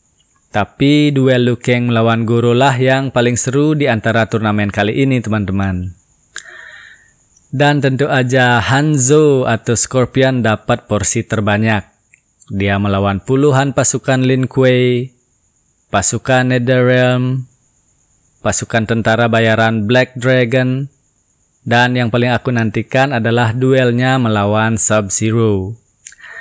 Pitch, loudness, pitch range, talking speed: 120 Hz, -13 LUFS, 110-130 Hz, 105 wpm